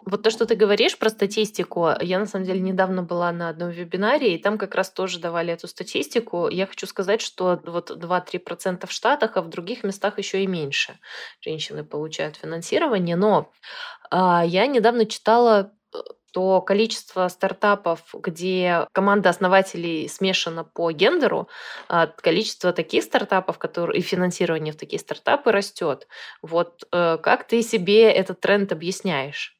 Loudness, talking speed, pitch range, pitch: -22 LUFS, 145 wpm, 175-210 Hz, 190 Hz